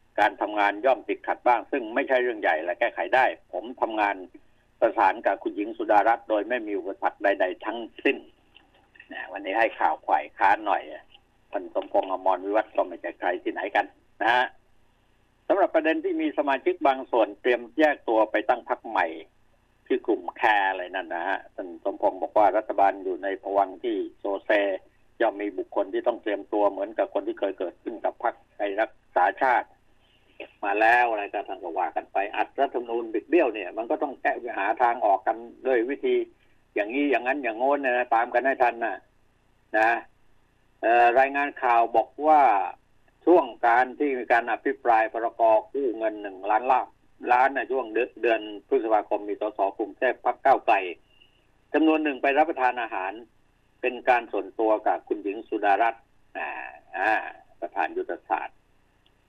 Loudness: -25 LUFS